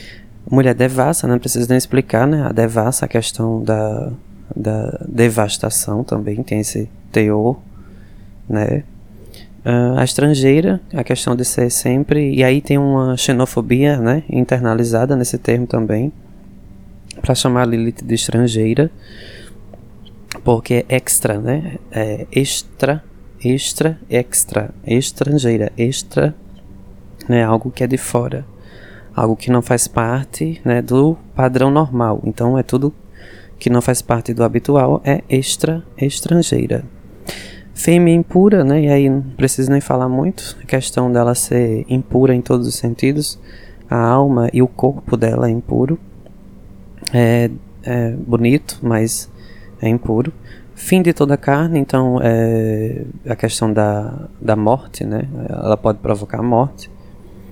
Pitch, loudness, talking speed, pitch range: 120 Hz, -16 LUFS, 135 wpm, 110-130 Hz